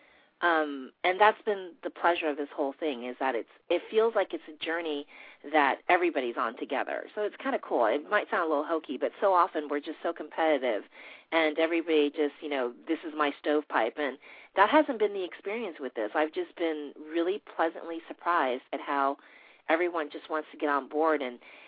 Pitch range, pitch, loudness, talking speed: 145-175 Hz, 160 Hz, -29 LUFS, 205 wpm